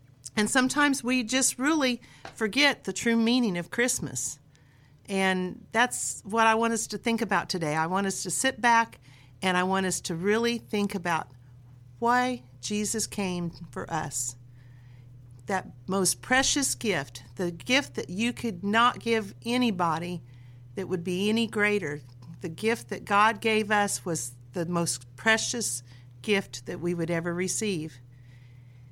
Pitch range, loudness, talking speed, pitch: 135-225 Hz, -27 LUFS, 150 wpm, 185 Hz